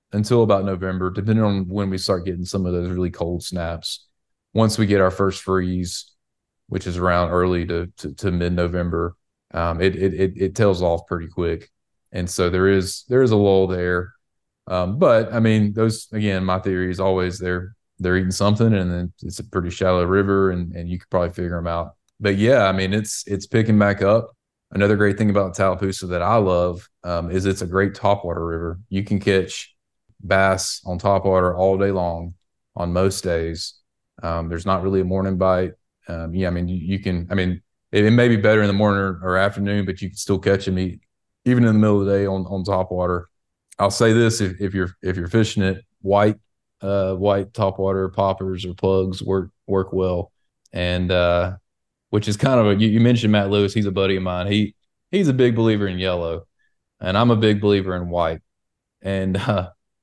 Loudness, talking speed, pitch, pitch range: -20 LUFS, 215 wpm, 95 Hz, 90-100 Hz